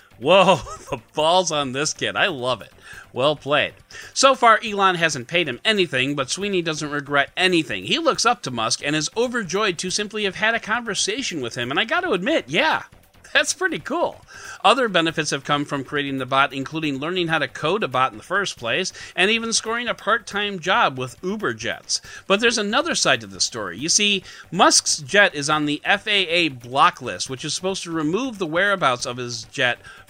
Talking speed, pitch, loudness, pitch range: 205 wpm, 175 Hz, -20 LUFS, 145-205 Hz